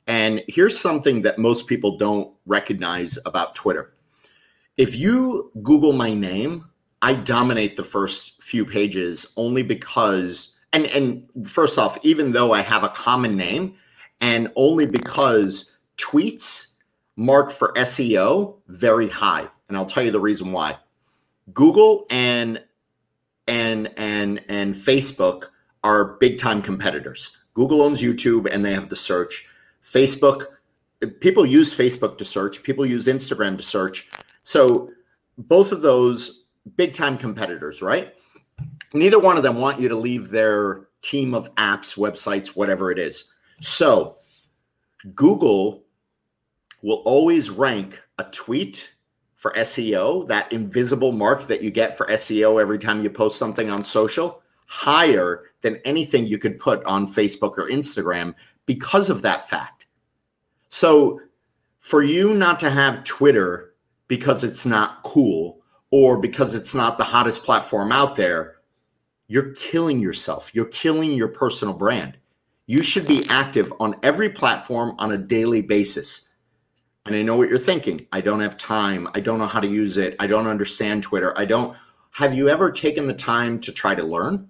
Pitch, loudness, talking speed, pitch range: 115 Hz, -20 LUFS, 150 wpm, 105-140 Hz